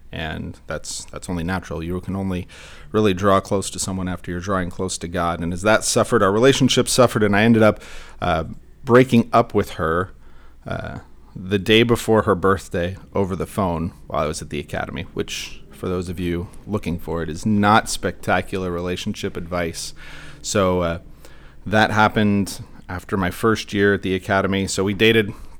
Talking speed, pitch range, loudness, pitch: 180 wpm, 90-105 Hz, -20 LUFS, 95 Hz